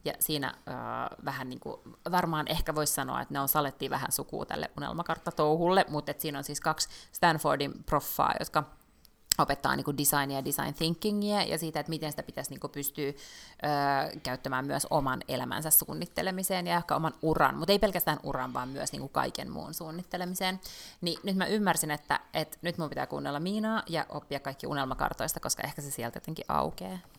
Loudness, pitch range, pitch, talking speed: -31 LUFS, 145-180 Hz, 155 Hz, 180 wpm